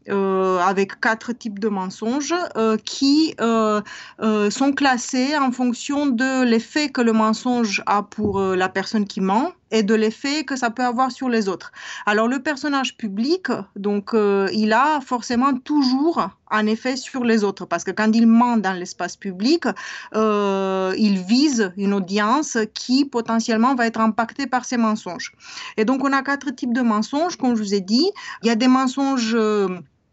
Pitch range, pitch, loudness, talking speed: 210-260 Hz, 225 Hz, -20 LUFS, 180 wpm